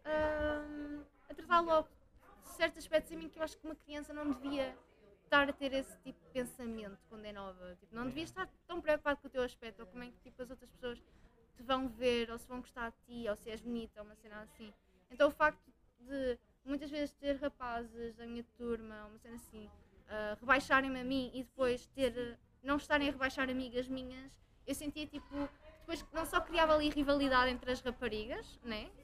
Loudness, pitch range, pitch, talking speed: -37 LUFS, 235-295 Hz, 260 Hz, 215 wpm